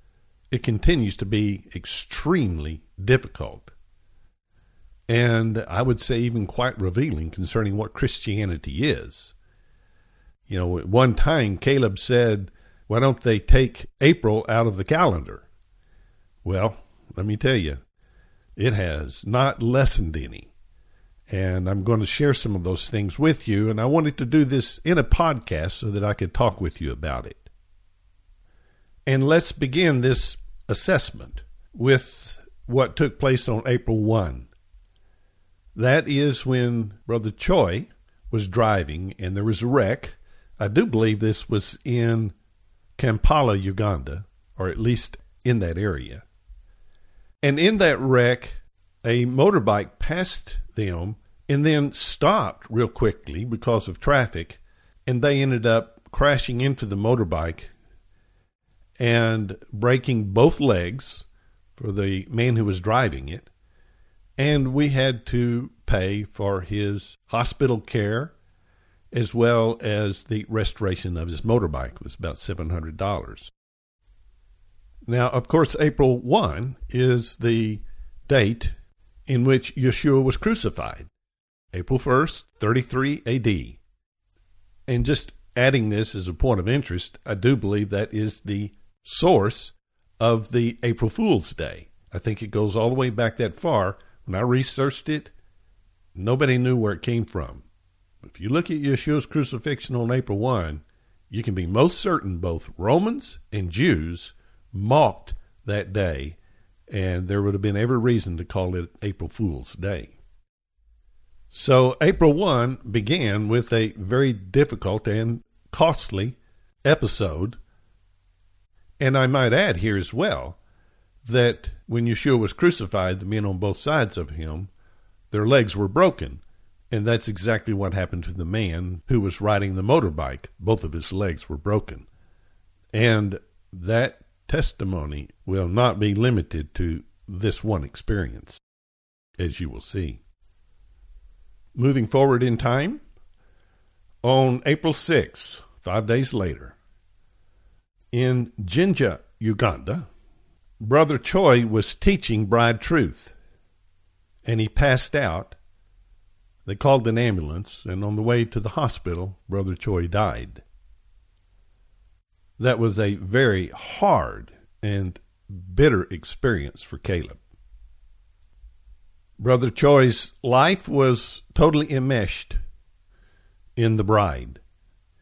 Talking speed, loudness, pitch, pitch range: 130 wpm, -23 LUFS, 105 Hz, 90-120 Hz